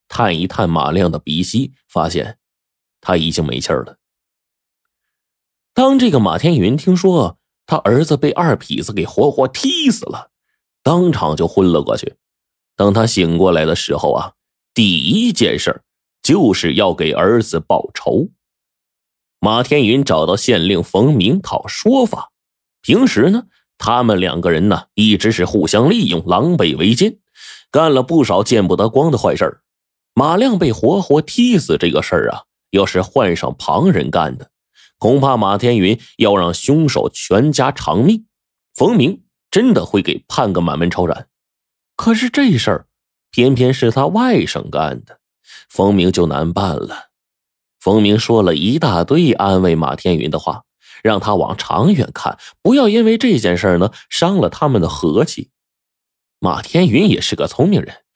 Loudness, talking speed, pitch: -14 LUFS, 225 characters per minute, 120 Hz